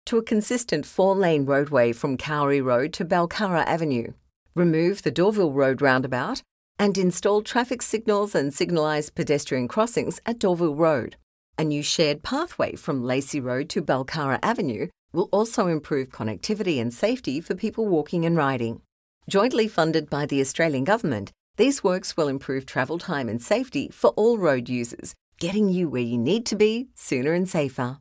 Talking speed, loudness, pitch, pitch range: 165 wpm, -24 LUFS, 160 Hz, 135-205 Hz